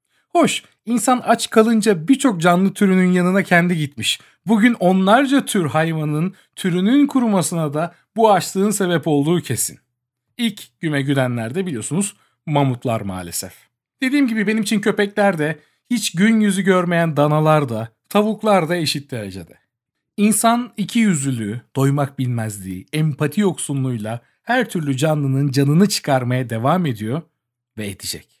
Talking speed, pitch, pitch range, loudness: 130 wpm, 170 Hz, 135-205 Hz, -18 LUFS